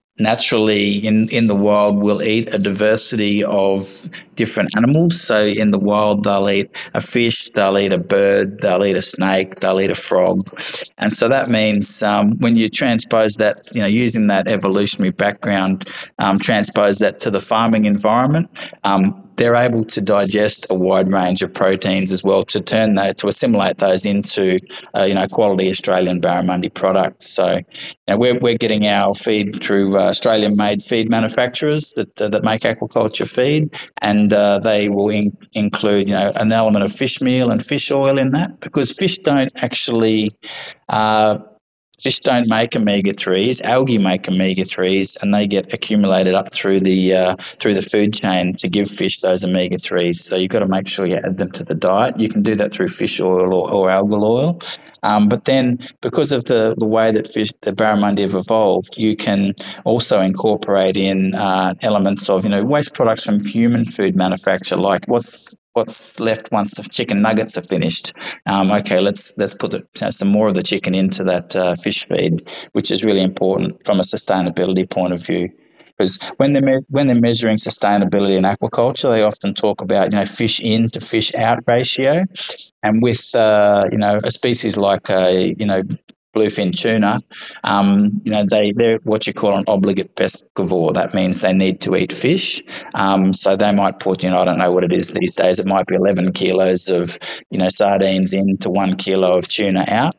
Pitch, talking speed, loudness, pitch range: 105 Hz, 195 wpm, -16 LUFS, 95-110 Hz